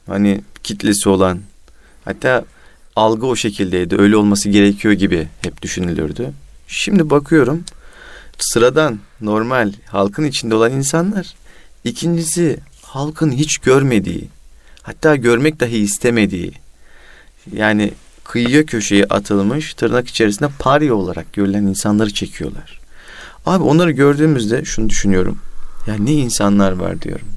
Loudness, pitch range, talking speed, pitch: -15 LUFS, 100-145 Hz, 110 wpm, 110 Hz